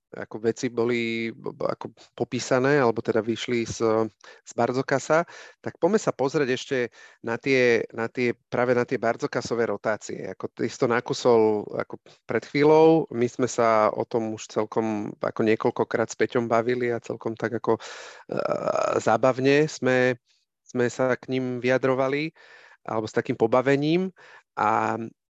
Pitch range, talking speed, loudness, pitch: 115-130 Hz, 150 wpm, -24 LUFS, 120 Hz